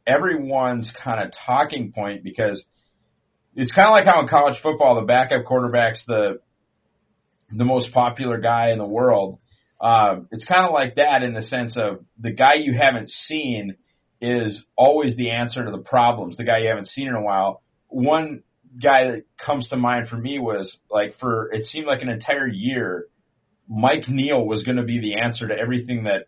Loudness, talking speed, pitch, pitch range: -20 LUFS, 190 wpm, 120 Hz, 115-130 Hz